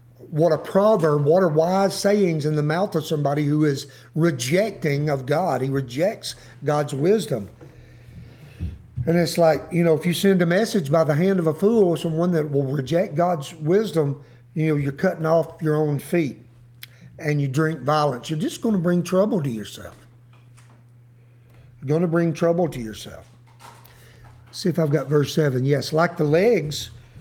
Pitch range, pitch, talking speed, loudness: 125-170 Hz, 150 Hz, 180 wpm, -21 LUFS